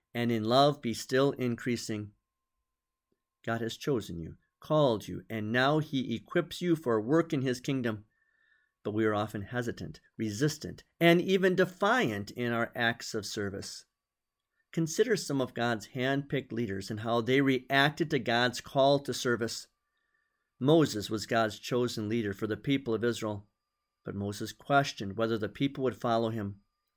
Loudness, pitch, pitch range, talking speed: -30 LUFS, 120 Hz, 110-140 Hz, 160 wpm